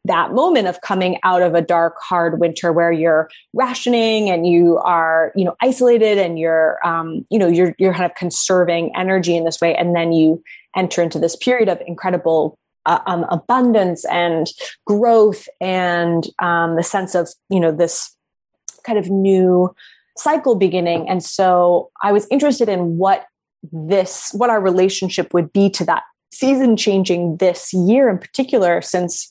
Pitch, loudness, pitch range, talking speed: 180 Hz, -16 LUFS, 170-205 Hz, 170 wpm